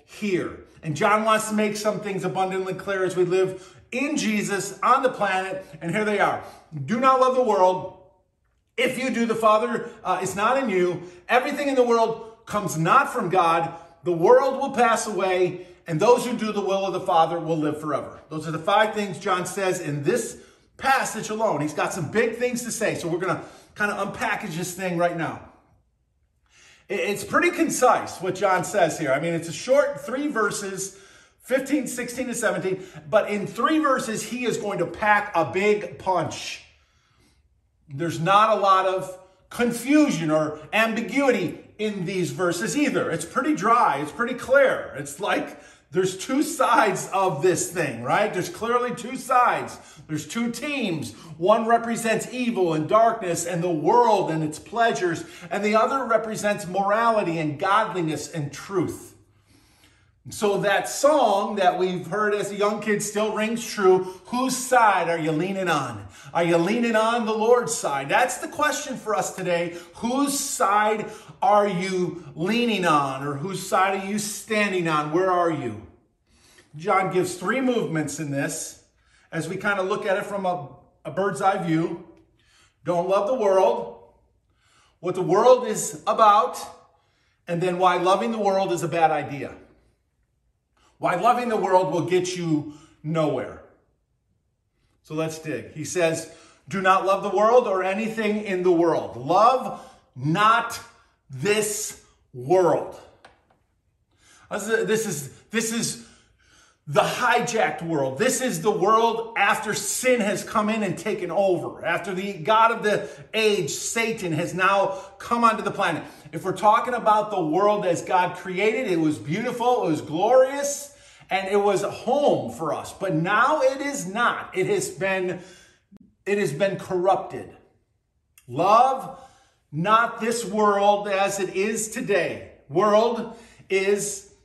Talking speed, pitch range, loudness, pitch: 165 wpm, 170-225 Hz, -23 LUFS, 195 Hz